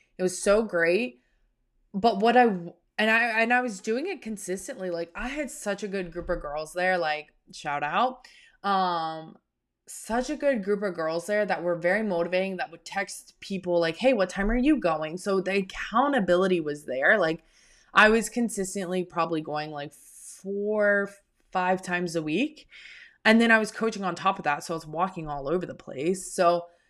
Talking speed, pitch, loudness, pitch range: 190 wpm, 190 Hz, -26 LUFS, 170-220 Hz